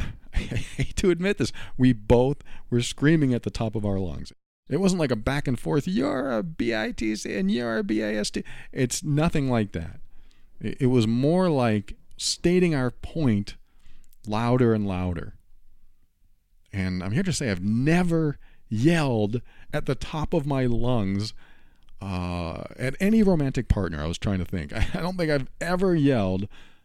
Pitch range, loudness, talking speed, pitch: 100-150 Hz, -25 LUFS, 165 wpm, 120 Hz